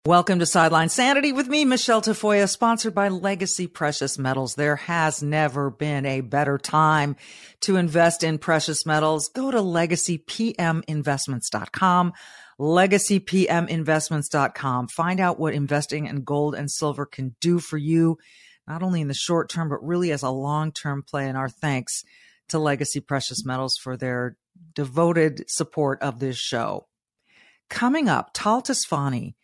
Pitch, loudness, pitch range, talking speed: 155 Hz, -23 LUFS, 145-175 Hz, 145 wpm